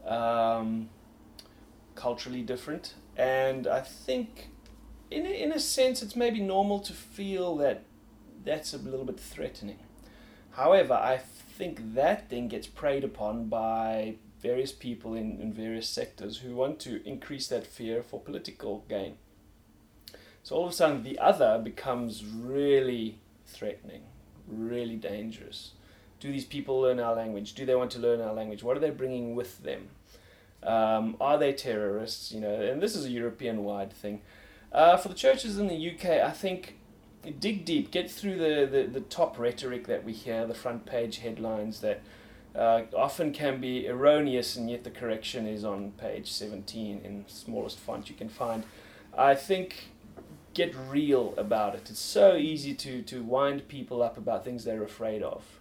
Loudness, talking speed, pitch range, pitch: -30 LUFS, 165 wpm, 110-140 Hz, 120 Hz